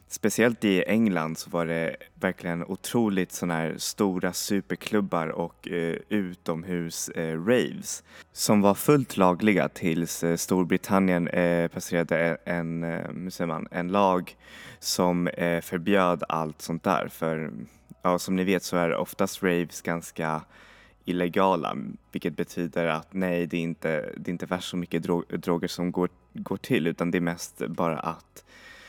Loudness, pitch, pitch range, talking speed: -27 LUFS, 90 Hz, 85-95 Hz, 155 wpm